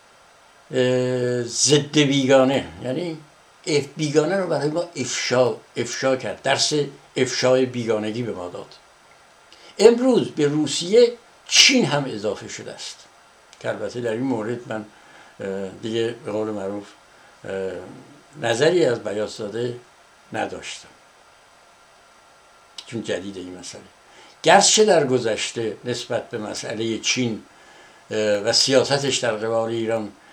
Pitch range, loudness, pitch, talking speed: 115-150 Hz, -21 LUFS, 125 Hz, 110 wpm